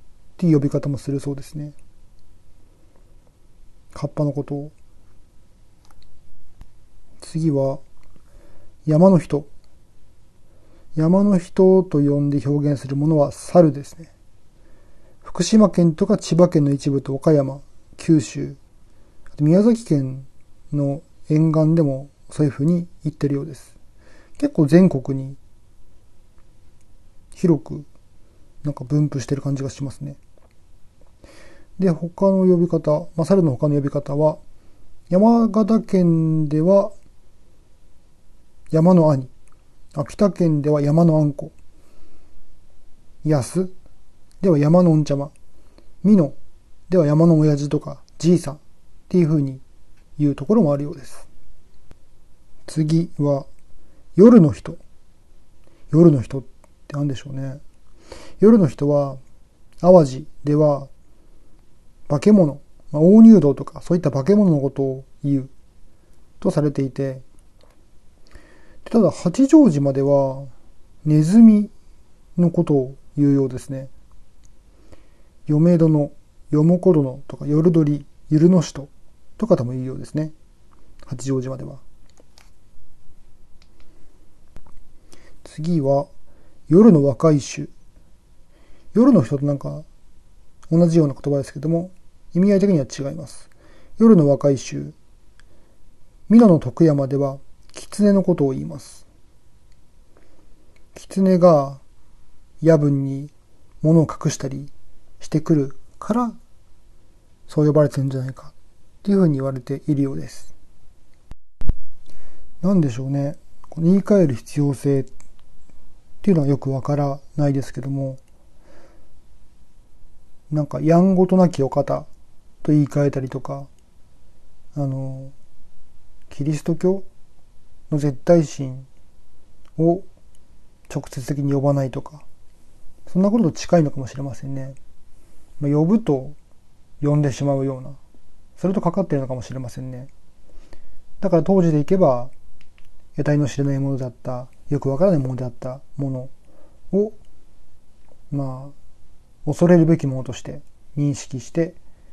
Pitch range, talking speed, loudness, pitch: 110-160 Hz, 225 characters per minute, -18 LUFS, 140 Hz